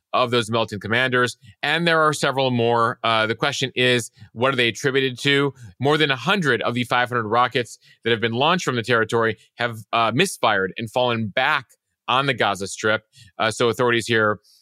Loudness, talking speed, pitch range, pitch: -20 LUFS, 190 wpm, 115-135 Hz, 120 Hz